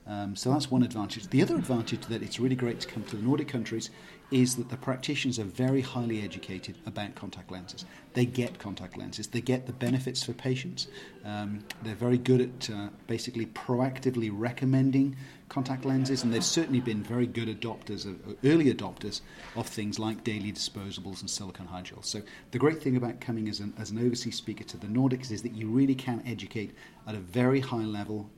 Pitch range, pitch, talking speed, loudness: 105-125 Hz, 115 Hz, 200 wpm, -31 LUFS